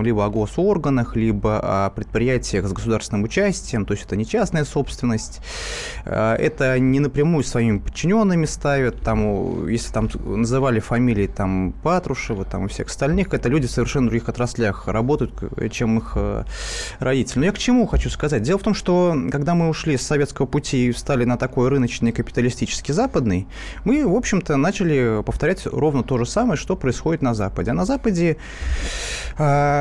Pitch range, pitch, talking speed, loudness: 110-150 Hz, 125 Hz, 165 wpm, -21 LUFS